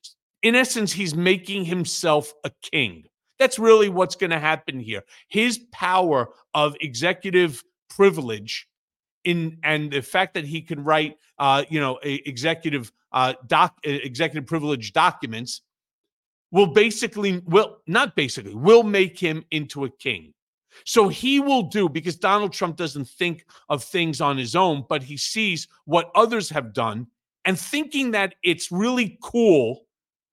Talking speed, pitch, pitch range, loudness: 145 wpm, 170 Hz, 145-200 Hz, -22 LUFS